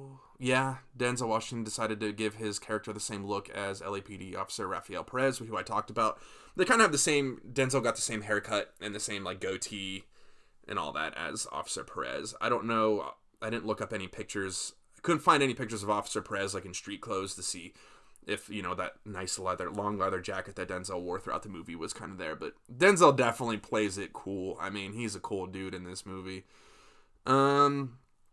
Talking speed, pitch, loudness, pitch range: 210 wpm, 105 Hz, -32 LUFS, 95-115 Hz